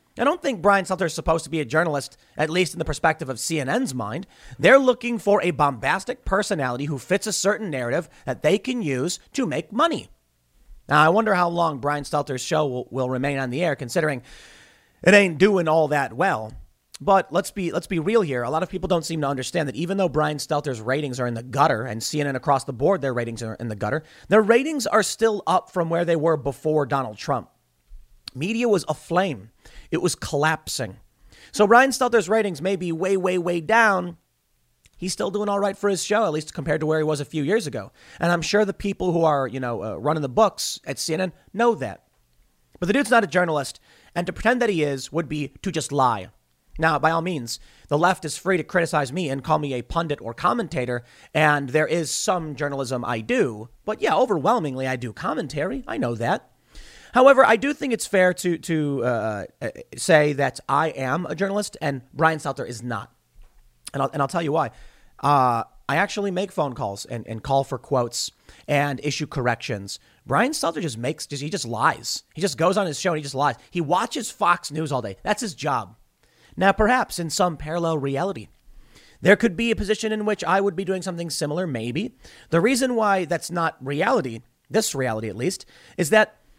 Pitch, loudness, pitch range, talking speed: 160 Hz, -23 LUFS, 135-195 Hz, 215 wpm